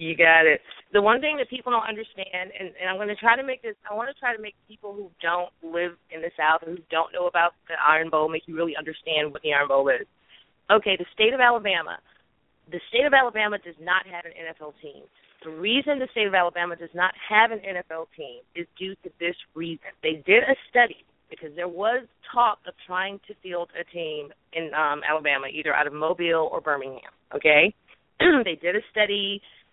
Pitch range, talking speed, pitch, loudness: 160-215 Hz, 220 wpm, 180 Hz, -23 LUFS